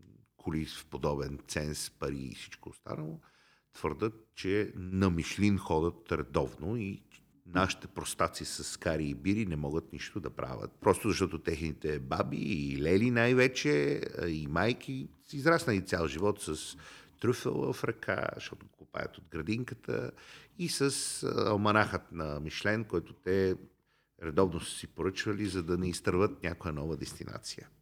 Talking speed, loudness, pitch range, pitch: 140 wpm, -33 LUFS, 80-105 Hz, 90 Hz